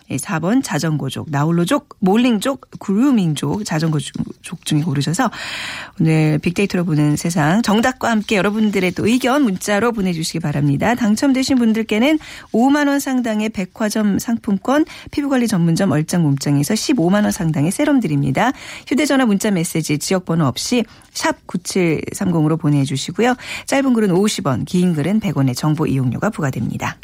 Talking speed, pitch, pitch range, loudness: 335 characters per minute, 195 Hz, 155-230 Hz, -17 LUFS